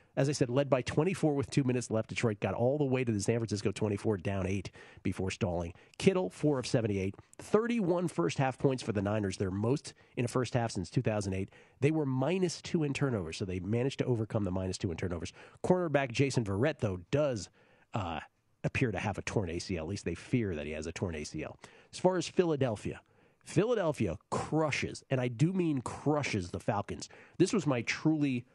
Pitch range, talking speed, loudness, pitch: 100-140 Hz, 205 wpm, -33 LUFS, 120 Hz